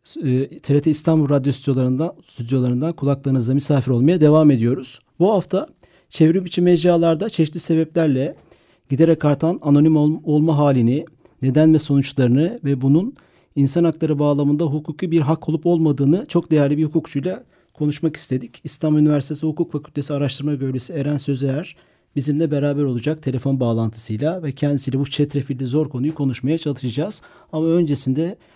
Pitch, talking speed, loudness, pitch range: 150 Hz, 135 wpm, -19 LUFS, 140-160 Hz